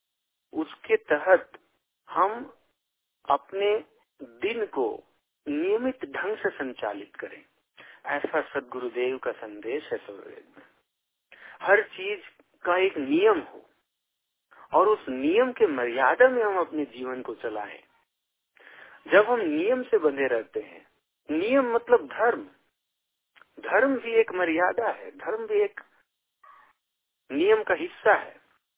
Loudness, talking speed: -26 LUFS, 115 wpm